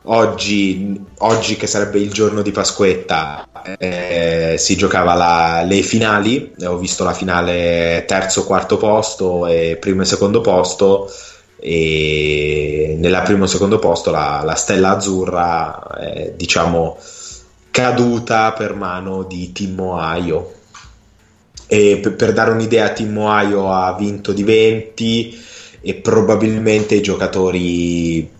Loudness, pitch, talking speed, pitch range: -15 LUFS, 95 Hz, 130 wpm, 85-105 Hz